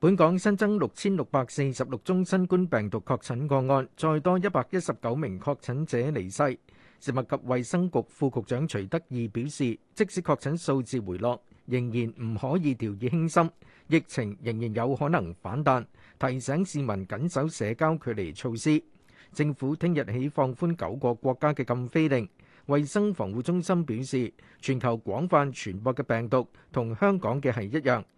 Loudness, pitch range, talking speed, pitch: -28 LUFS, 120-160 Hz, 265 characters per minute, 135 Hz